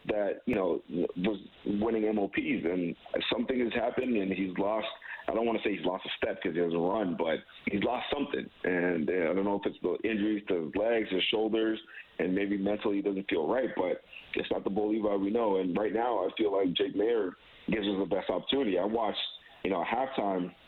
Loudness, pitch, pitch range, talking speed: -31 LUFS, 100 Hz, 95-105 Hz, 230 wpm